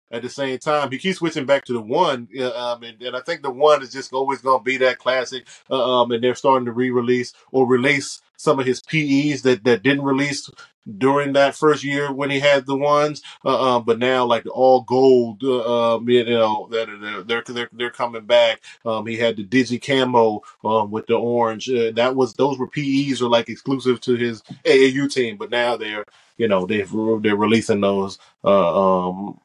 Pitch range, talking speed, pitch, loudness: 115-135 Hz, 210 wpm, 125 Hz, -19 LUFS